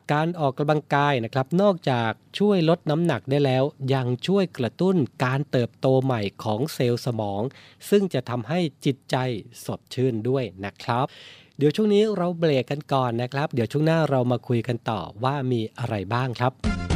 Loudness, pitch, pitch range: -24 LUFS, 130 Hz, 120-150 Hz